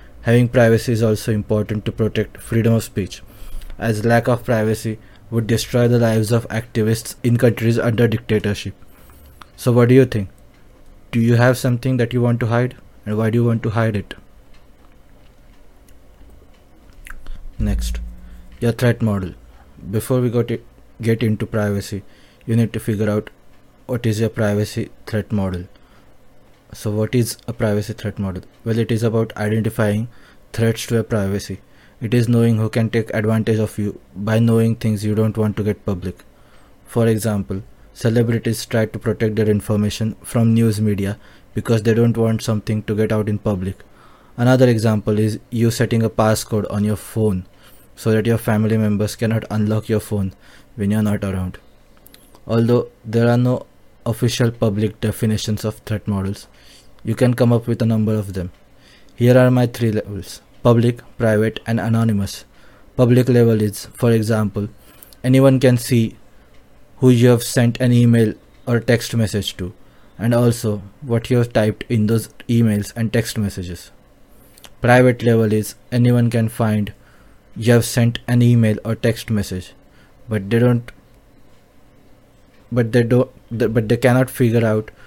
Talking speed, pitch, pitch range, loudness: 160 wpm, 110 Hz, 105-120 Hz, -18 LUFS